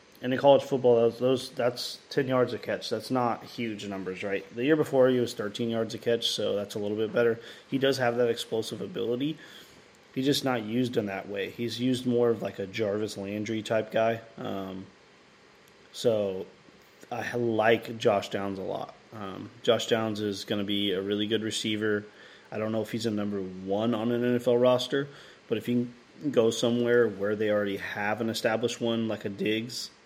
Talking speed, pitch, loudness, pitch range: 200 wpm, 115 Hz, -28 LUFS, 105-120 Hz